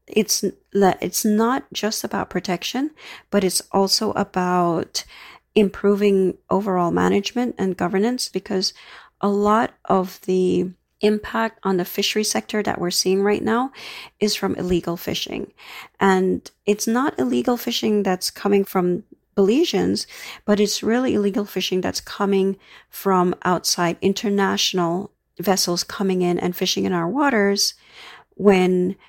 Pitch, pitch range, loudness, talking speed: 195 Hz, 185-210 Hz, -21 LUFS, 130 wpm